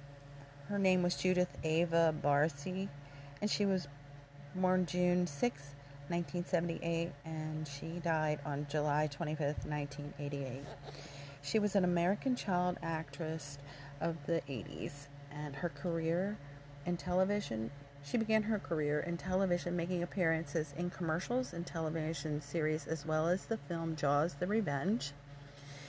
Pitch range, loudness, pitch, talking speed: 145-180 Hz, -36 LUFS, 160 Hz, 130 wpm